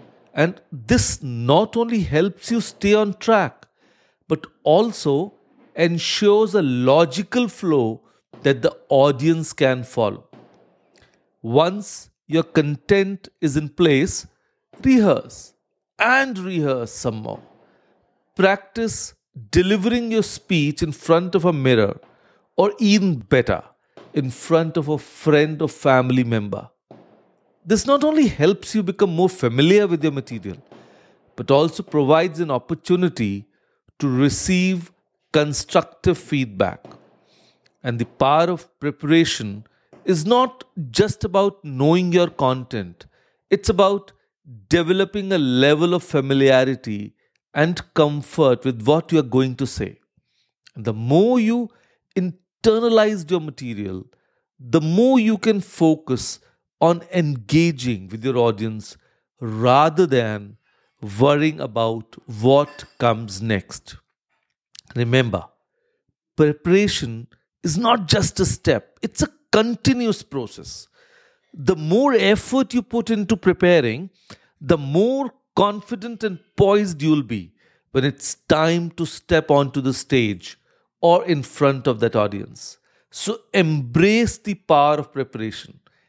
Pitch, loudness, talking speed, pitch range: 160 Hz, -19 LUFS, 115 wpm, 130-195 Hz